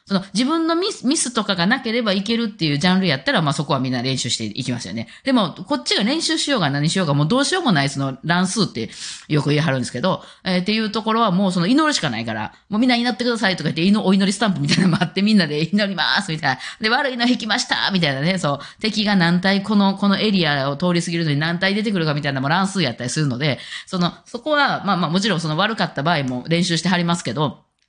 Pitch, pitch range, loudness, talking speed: 185 Hz, 155-220 Hz, -19 LUFS, 535 characters per minute